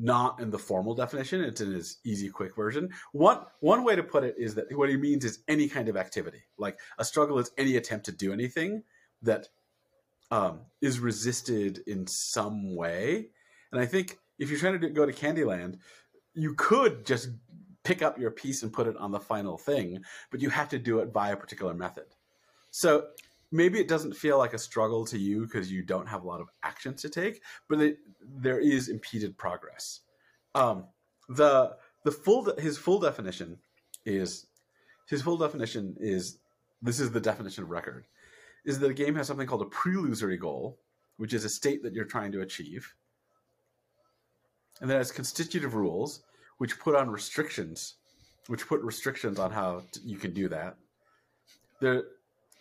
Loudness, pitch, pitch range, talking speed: -30 LUFS, 125 Hz, 105-145 Hz, 185 wpm